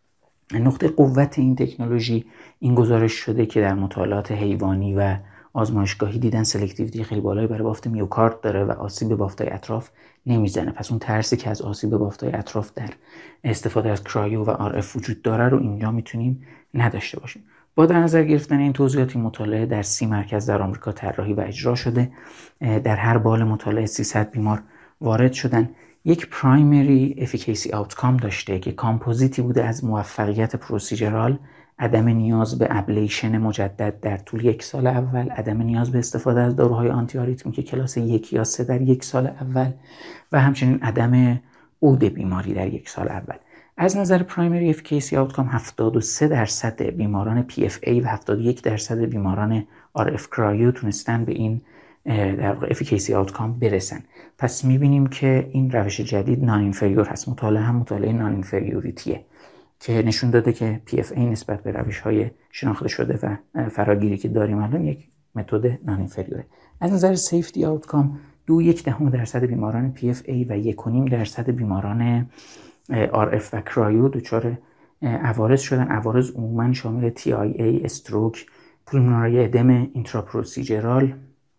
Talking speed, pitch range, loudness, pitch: 150 wpm, 105-125 Hz, -22 LUFS, 115 Hz